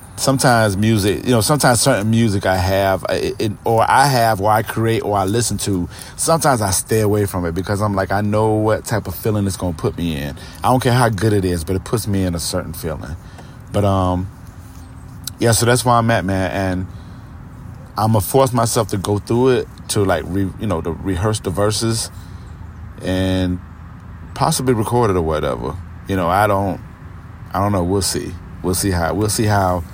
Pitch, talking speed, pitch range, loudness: 100 Hz, 205 wpm, 90-115 Hz, -17 LUFS